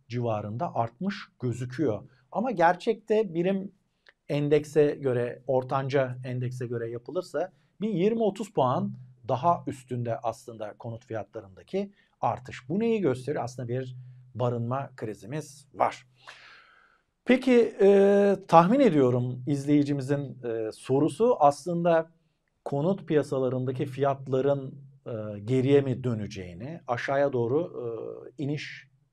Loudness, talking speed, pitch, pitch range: -27 LUFS, 100 wpm, 140 Hz, 125-170 Hz